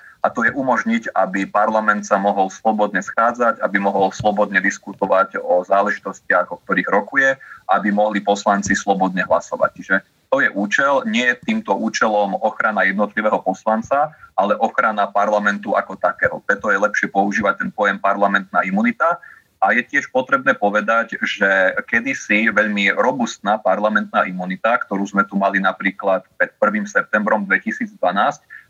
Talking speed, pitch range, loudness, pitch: 140 wpm, 100-120 Hz, -18 LUFS, 105 Hz